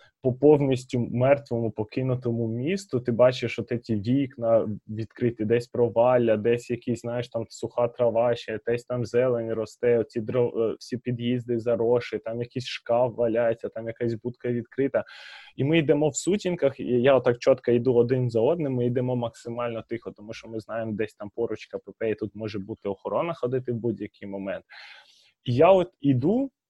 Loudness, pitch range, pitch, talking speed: -26 LUFS, 115-125 Hz, 120 Hz, 165 wpm